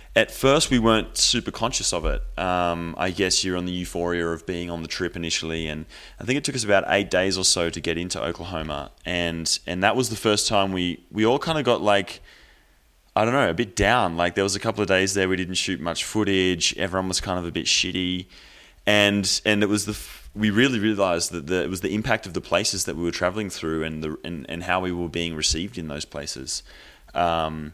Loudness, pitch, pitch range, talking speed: -23 LUFS, 90 Hz, 85-100 Hz, 240 wpm